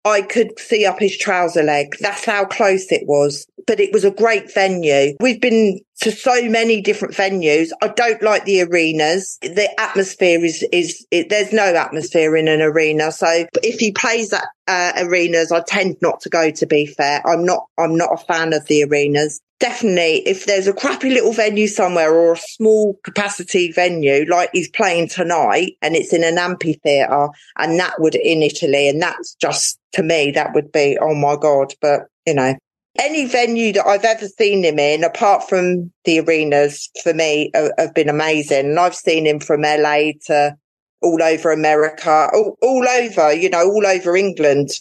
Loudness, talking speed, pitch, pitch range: -16 LUFS, 190 wpm, 175 Hz, 155-205 Hz